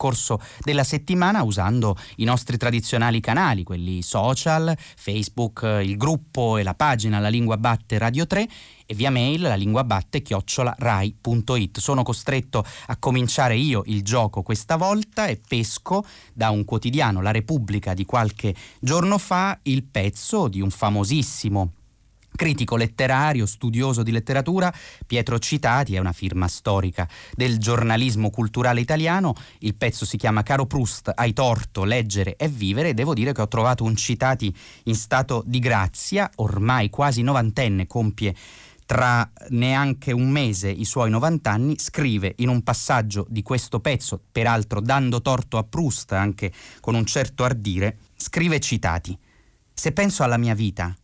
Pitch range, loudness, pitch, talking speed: 105-135 Hz, -22 LUFS, 120 Hz, 145 wpm